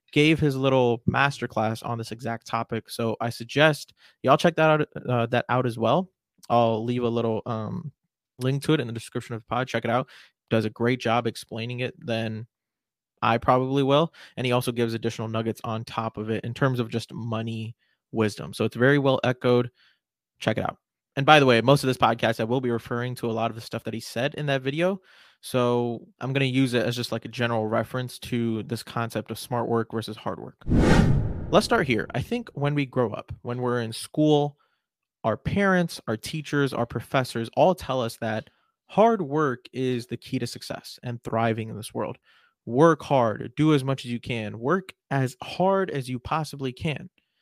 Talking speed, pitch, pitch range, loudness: 210 wpm, 120 Hz, 115-140 Hz, -25 LUFS